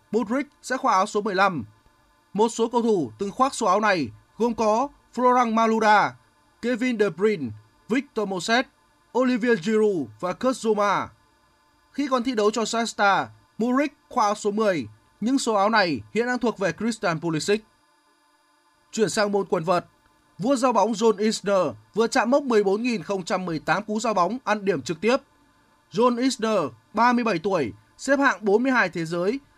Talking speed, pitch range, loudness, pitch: 160 wpm, 180-235 Hz, -23 LUFS, 215 Hz